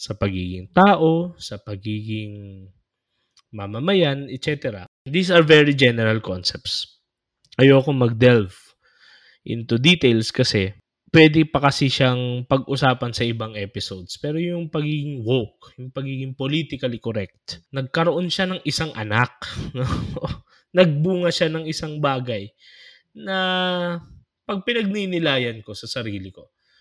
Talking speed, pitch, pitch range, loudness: 110 wpm, 130 Hz, 110-160 Hz, -20 LUFS